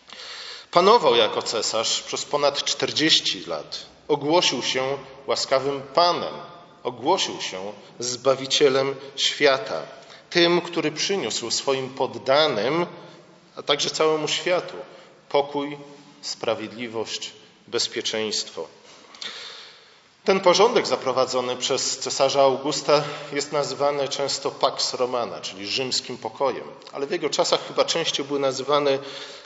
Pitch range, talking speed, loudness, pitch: 130-160 Hz, 100 wpm, -22 LUFS, 140 Hz